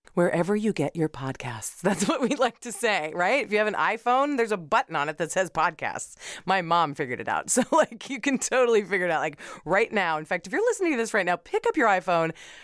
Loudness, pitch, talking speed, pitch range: -25 LUFS, 200 Hz, 255 wpm, 170-245 Hz